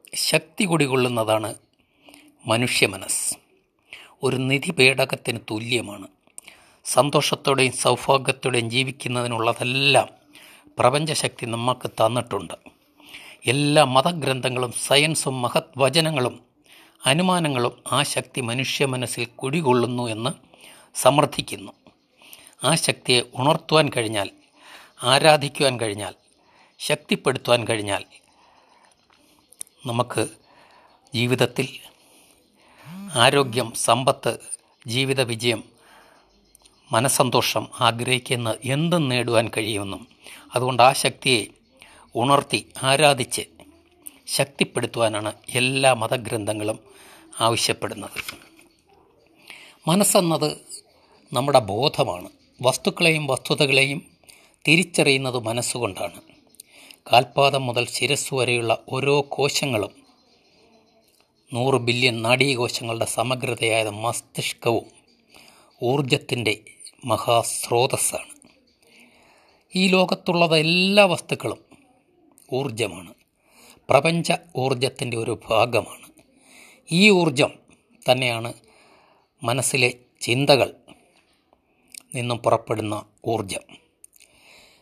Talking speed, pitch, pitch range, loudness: 65 wpm, 130 Hz, 120-145 Hz, -21 LUFS